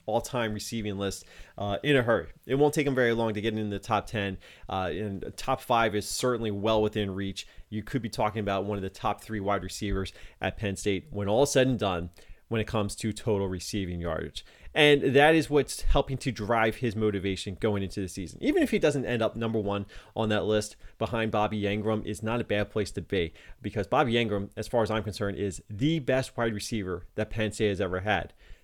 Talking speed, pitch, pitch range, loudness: 225 wpm, 105 Hz, 100-115 Hz, -29 LUFS